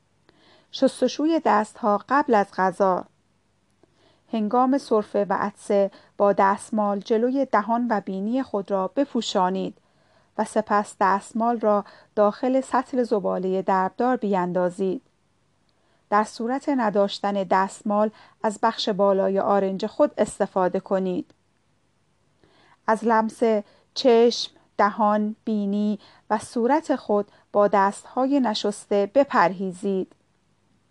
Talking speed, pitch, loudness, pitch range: 95 wpm, 210 Hz, -23 LUFS, 200-235 Hz